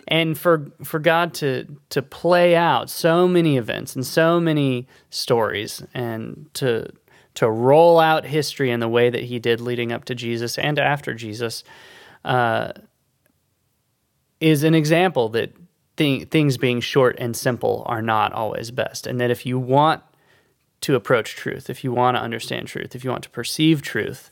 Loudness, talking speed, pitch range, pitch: -20 LUFS, 170 wpm, 120-160 Hz, 140 Hz